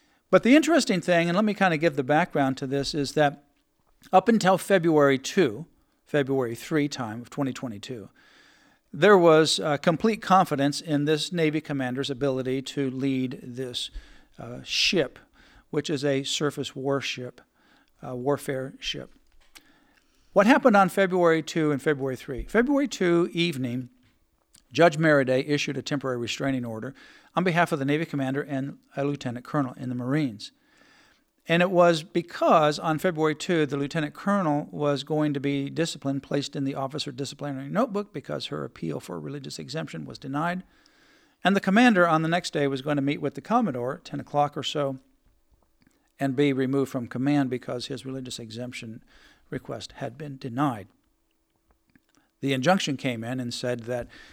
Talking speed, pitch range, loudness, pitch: 160 wpm, 135-175 Hz, -25 LUFS, 145 Hz